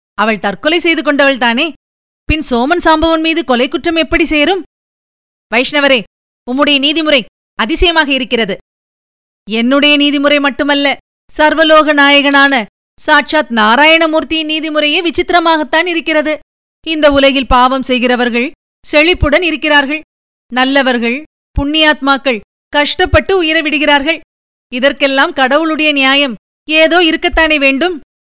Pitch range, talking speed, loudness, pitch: 270-320 Hz, 95 wpm, -10 LUFS, 295 Hz